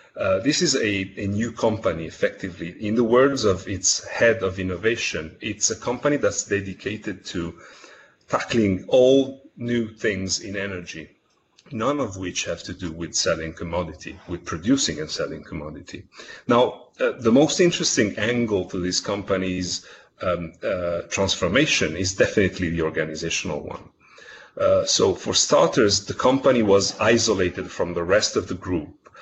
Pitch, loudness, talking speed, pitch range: 100 Hz, -22 LUFS, 150 wpm, 90-120 Hz